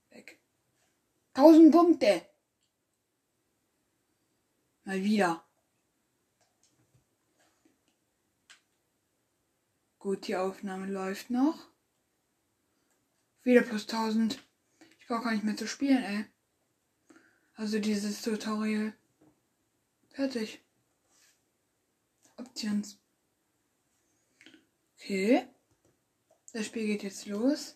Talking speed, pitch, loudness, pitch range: 65 wpm, 225 Hz, -28 LUFS, 210-275 Hz